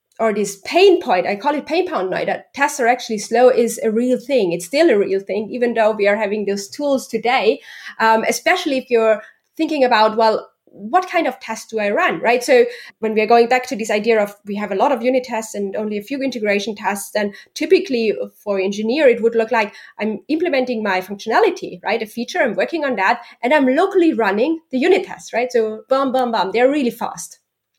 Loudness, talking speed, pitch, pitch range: -18 LUFS, 225 wpm, 230 Hz, 210-275 Hz